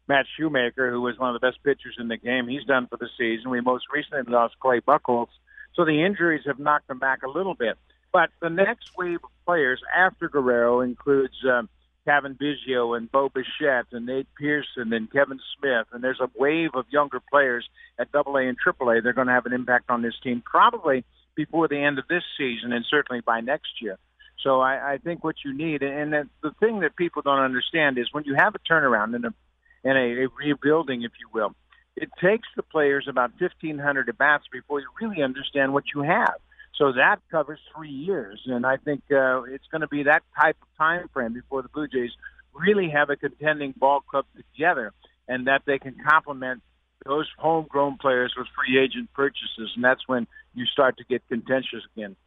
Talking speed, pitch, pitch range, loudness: 205 wpm, 135 Hz, 125-150 Hz, -24 LUFS